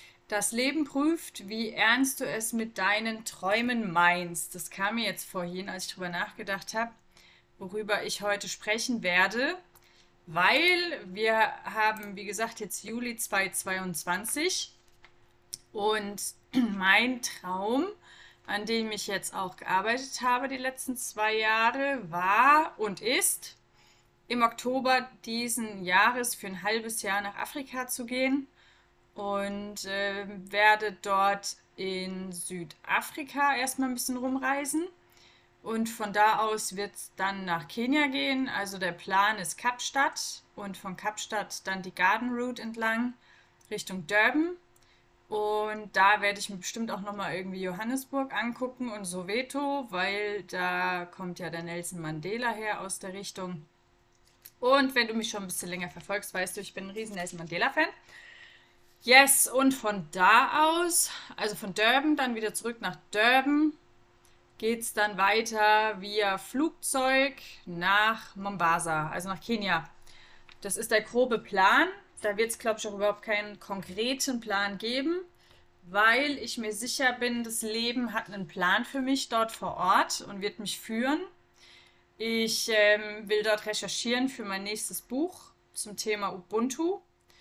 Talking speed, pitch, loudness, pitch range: 145 wpm, 215 Hz, -28 LUFS, 195-250 Hz